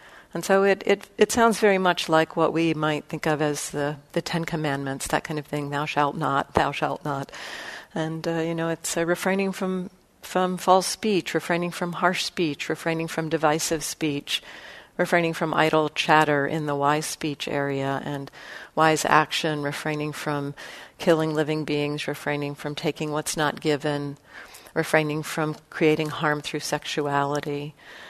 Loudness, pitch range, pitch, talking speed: -25 LUFS, 150-170 Hz, 155 Hz, 160 wpm